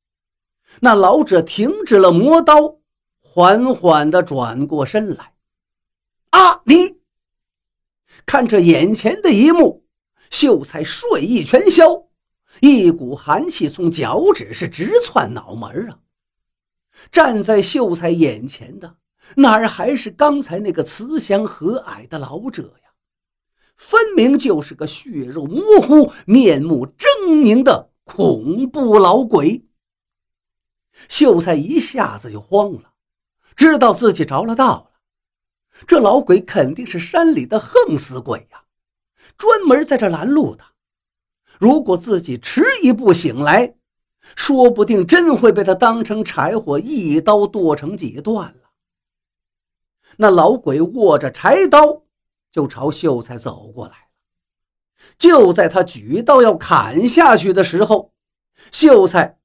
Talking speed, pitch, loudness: 180 characters per minute, 220 Hz, -13 LUFS